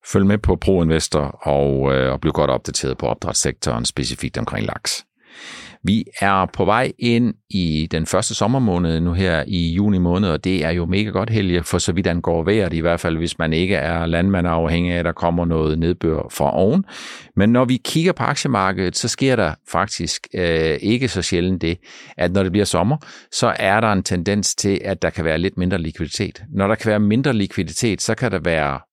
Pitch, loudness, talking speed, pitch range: 90 Hz, -19 LUFS, 210 wpm, 80-100 Hz